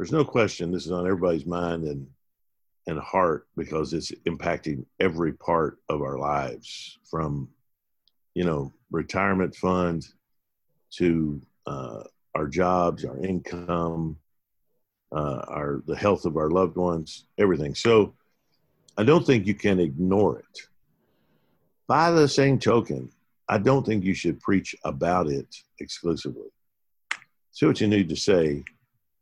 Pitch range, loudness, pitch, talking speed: 80-100 Hz, -25 LUFS, 90 Hz, 140 wpm